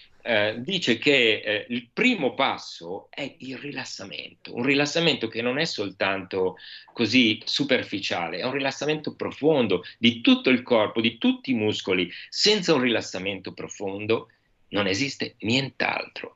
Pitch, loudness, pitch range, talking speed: 125 Hz, -24 LUFS, 105-145 Hz, 135 wpm